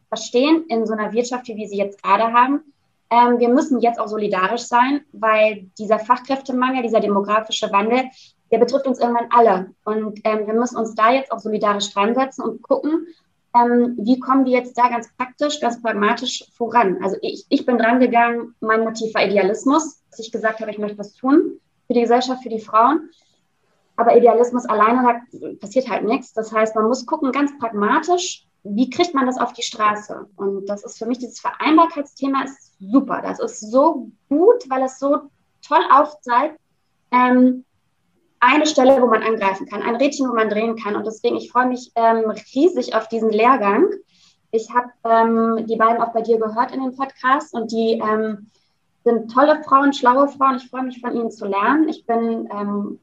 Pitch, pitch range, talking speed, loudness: 240 Hz, 220-265 Hz, 190 wpm, -18 LUFS